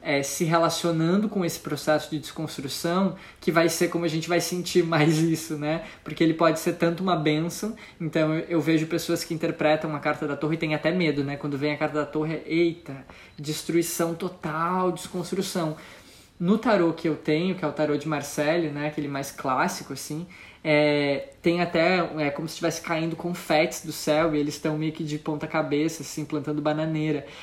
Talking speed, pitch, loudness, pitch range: 195 wpm, 160 Hz, -26 LUFS, 150-170 Hz